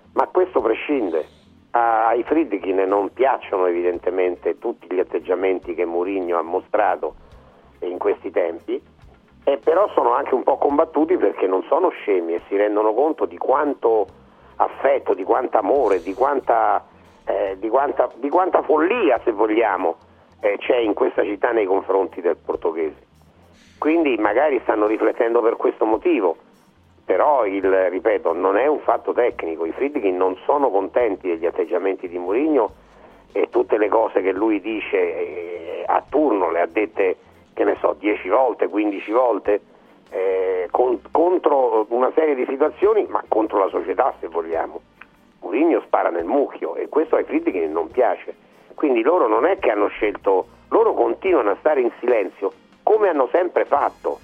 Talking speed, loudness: 155 wpm, -20 LUFS